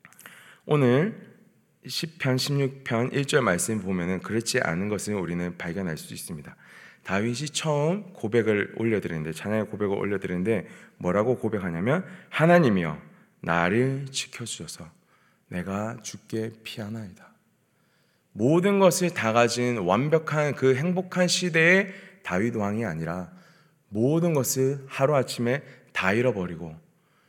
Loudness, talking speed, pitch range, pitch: -25 LUFS, 270 characters per minute, 105-150 Hz, 125 Hz